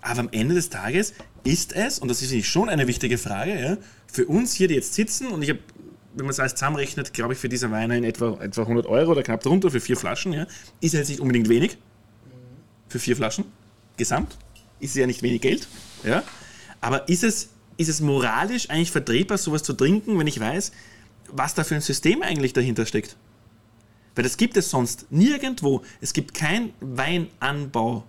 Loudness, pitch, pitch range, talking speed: -24 LUFS, 130 Hz, 115-165 Hz, 205 wpm